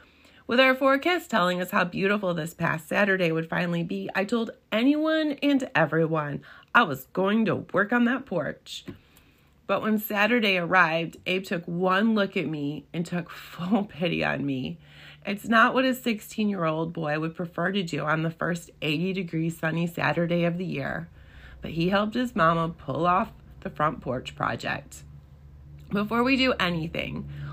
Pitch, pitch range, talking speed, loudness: 180 Hz, 160-215 Hz, 165 wpm, -26 LUFS